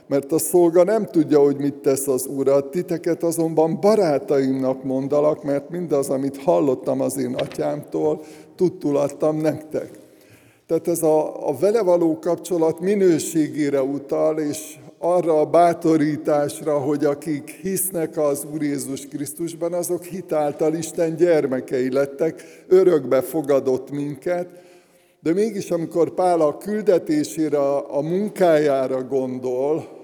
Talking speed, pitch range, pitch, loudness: 120 wpm, 140-175 Hz, 155 Hz, -21 LUFS